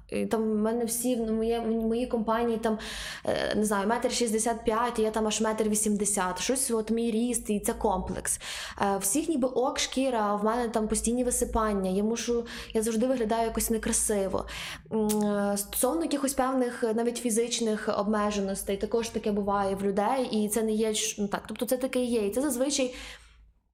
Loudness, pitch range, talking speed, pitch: -28 LUFS, 210-240 Hz, 165 wpm, 225 Hz